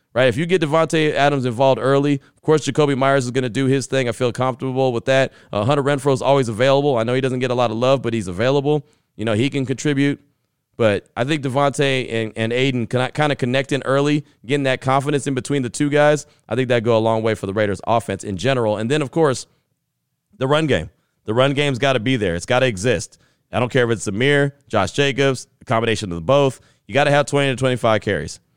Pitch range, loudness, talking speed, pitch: 120-140 Hz, -19 LUFS, 250 wpm, 130 Hz